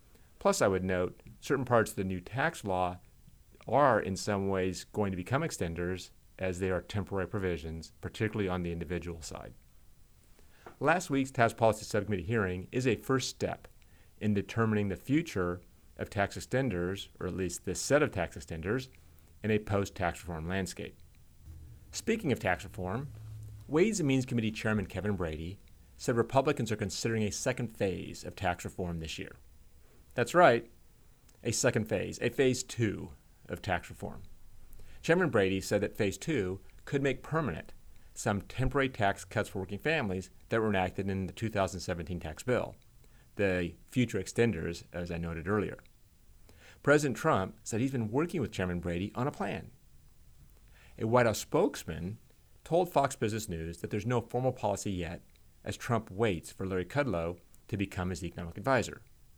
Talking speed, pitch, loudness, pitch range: 165 wpm, 100 Hz, -32 LUFS, 90-115 Hz